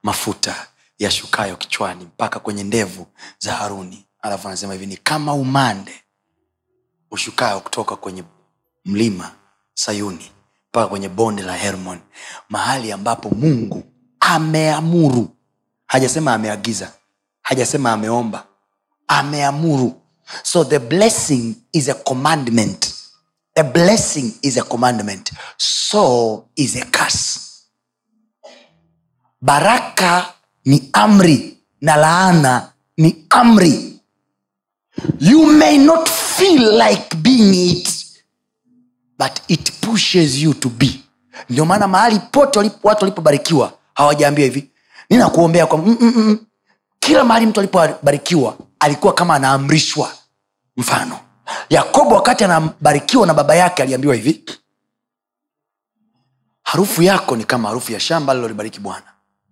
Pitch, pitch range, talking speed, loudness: 150 Hz, 115-185 Hz, 105 wpm, -15 LUFS